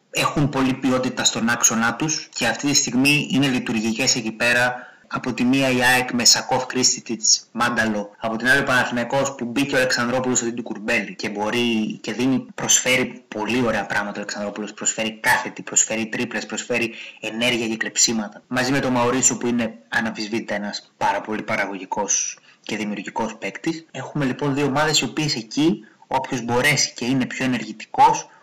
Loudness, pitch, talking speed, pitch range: -20 LUFS, 125 Hz, 170 wpm, 115-130 Hz